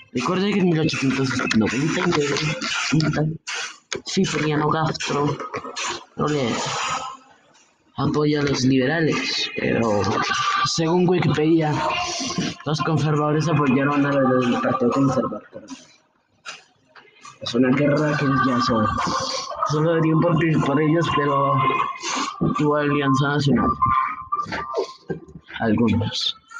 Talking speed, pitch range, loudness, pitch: 85 wpm, 140-180 Hz, -21 LUFS, 150 Hz